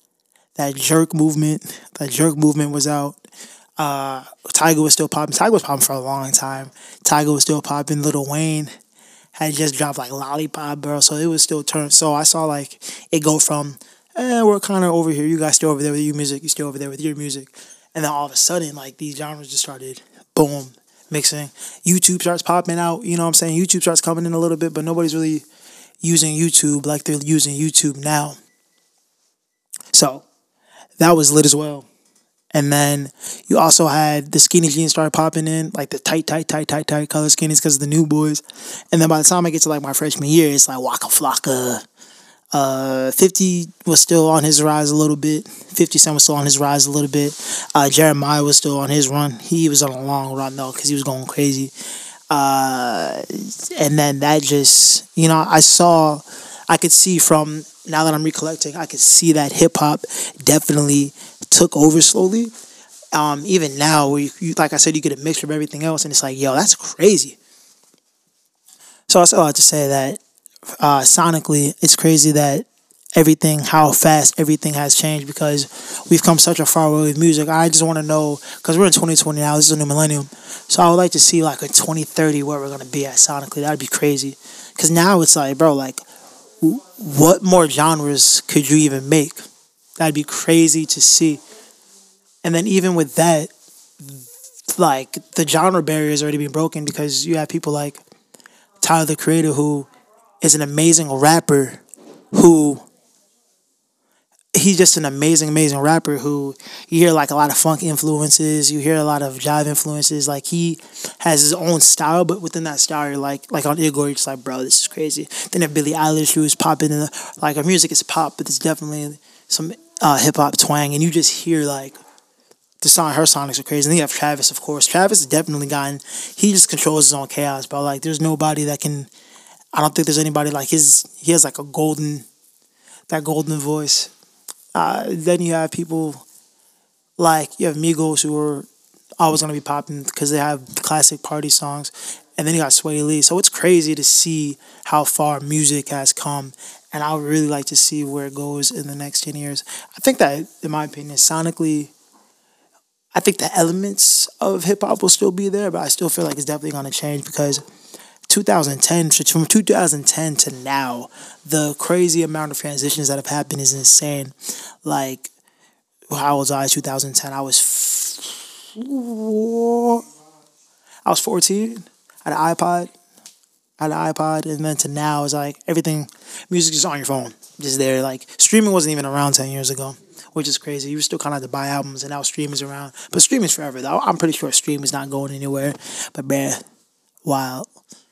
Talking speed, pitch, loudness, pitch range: 200 wpm, 150 Hz, -15 LUFS, 145-165 Hz